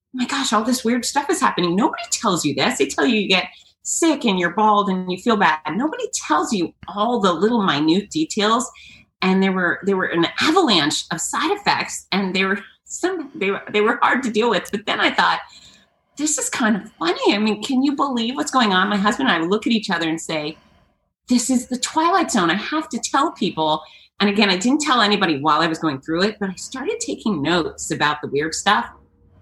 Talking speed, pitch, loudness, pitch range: 235 wpm, 210 Hz, -19 LUFS, 180-255 Hz